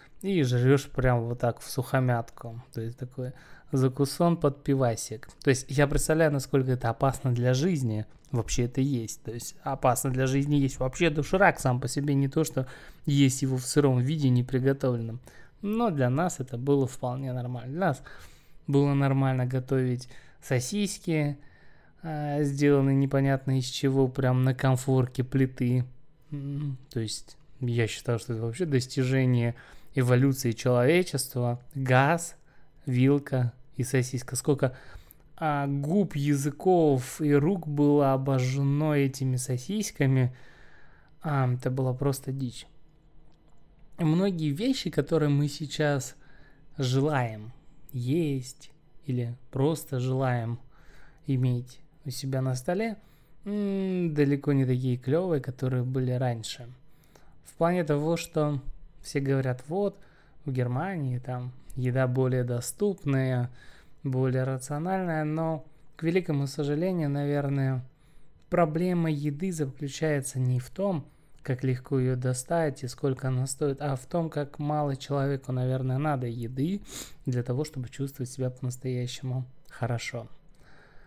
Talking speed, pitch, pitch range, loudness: 125 wpm, 135 Hz, 130-150 Hz, -28 LUFS